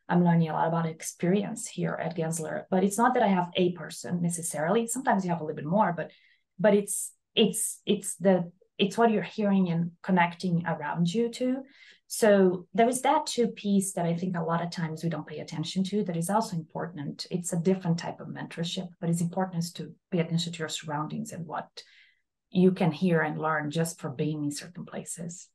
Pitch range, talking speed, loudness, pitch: 165-205 Hz, 210 wpm, -28 LUFS, 180 Hz